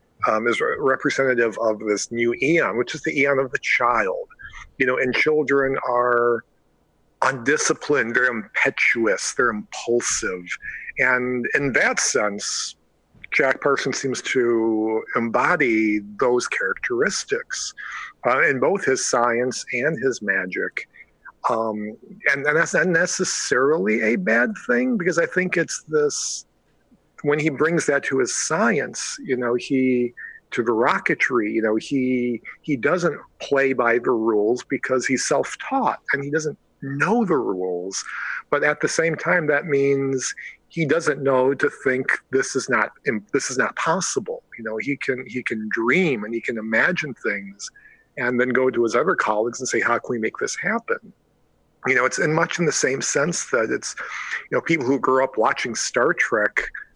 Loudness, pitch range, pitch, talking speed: -21 LUFS, 115-145 Hz, 130 Hz, 165 wpm